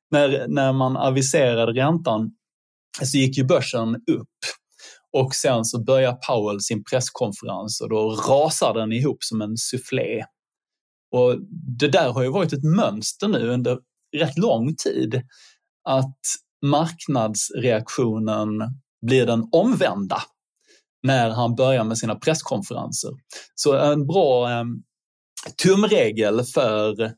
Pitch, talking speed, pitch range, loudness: 125 Hz, 120 wpm, 115-140 Hz, -21 LUFS